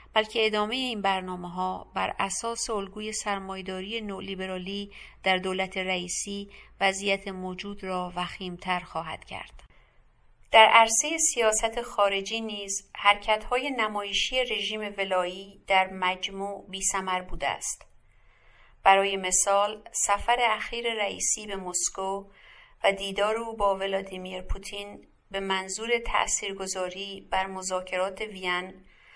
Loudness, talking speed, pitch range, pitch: -27 LUFS, 110 wpm, 190-215 Hz, 195 Hz